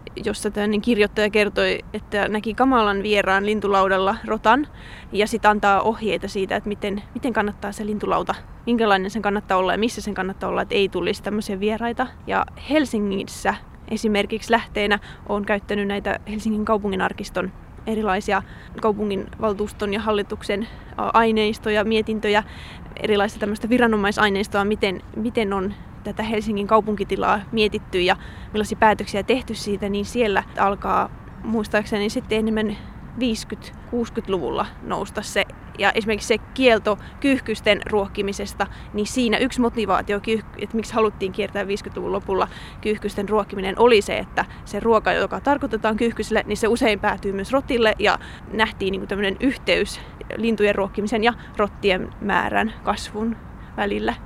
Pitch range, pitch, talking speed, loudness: 205-220 Hz, 210 Hz, 130 wpm, -22 LUFS